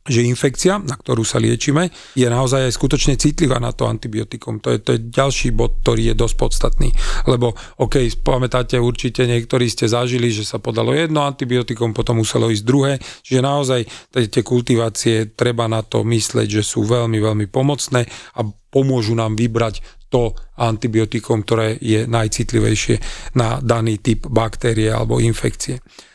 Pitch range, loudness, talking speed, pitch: 115-130 Hz, -18 LUFS, 155 wpm, 120 Hz